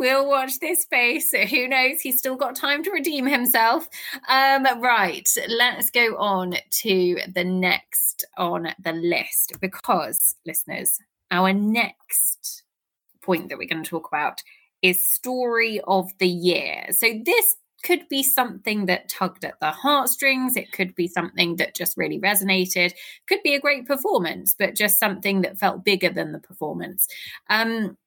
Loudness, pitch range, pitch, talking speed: -21 LUFS, 185-270 Hz, 220 Hz, 155 wpm